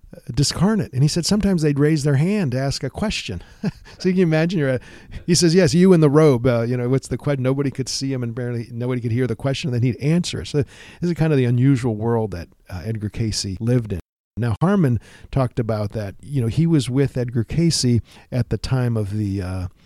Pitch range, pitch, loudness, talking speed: 115-150 Hz, 130 Hz, -20 LUFS, 240 wpm